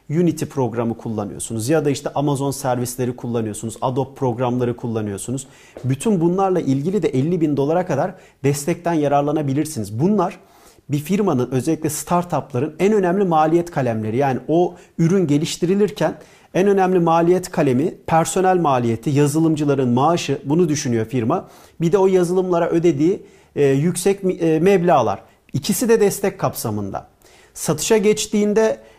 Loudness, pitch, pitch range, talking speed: -19 LUFS, 155 Hz, 130-180 Hz, 120 wpm